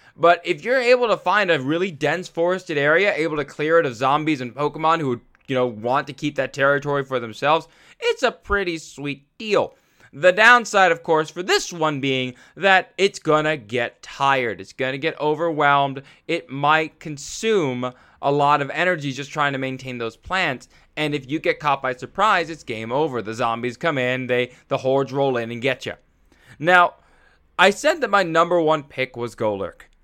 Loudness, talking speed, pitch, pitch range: -20 LUFS, 200 wpm, 150 Hz, 130-170 Hz